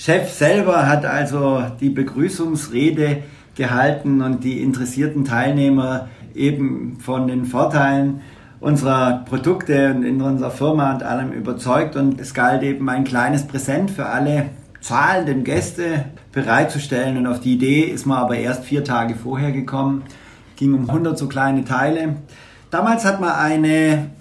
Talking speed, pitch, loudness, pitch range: 145 wpm, 135 Hz, -19 LUFS, 130-145 Hz